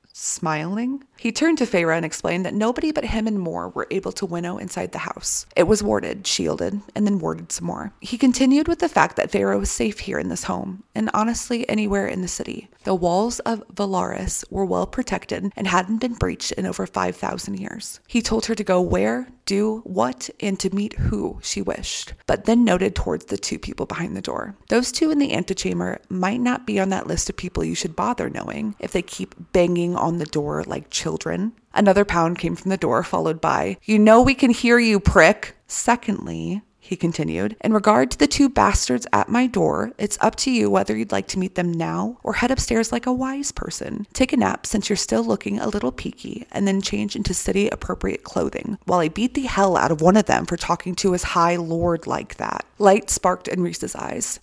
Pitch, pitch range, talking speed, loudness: 200 Hz, 175-230 Hz, 220 wpm, -21 LUFS